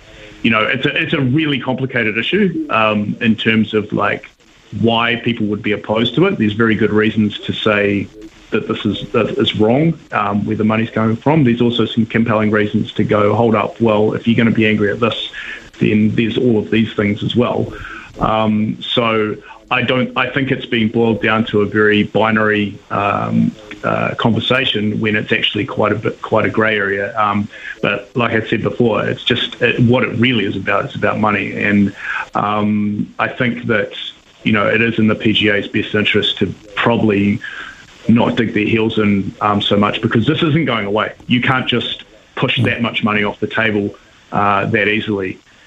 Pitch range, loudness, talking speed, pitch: 105-120 Hz, -15 LUFS, 195 wpm, 110 Hz